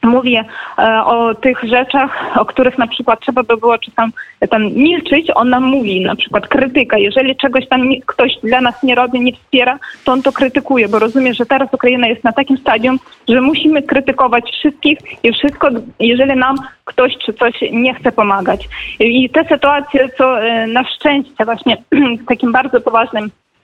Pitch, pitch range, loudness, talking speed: 255 Hz, 230-270 Hz, -12 LUFS, 175 wpm